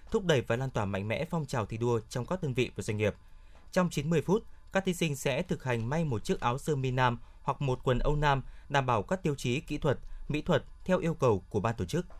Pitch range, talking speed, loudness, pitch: 115-160 Hz, 270 wpm, -31 LUFS, 135 Hz